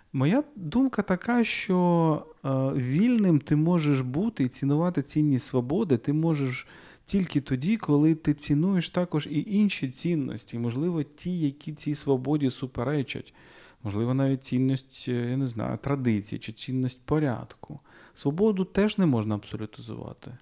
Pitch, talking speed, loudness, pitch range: 145 Hz, 130 wpm, -27 LUFS, 130-175 Hz